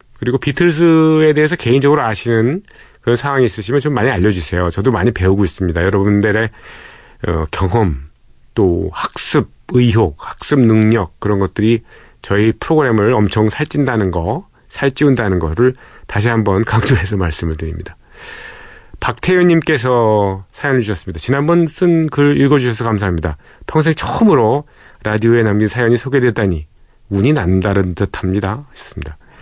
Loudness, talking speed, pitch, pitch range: -14 LUFS, 340 characters per minute, 115 Hz, 95-140 Hz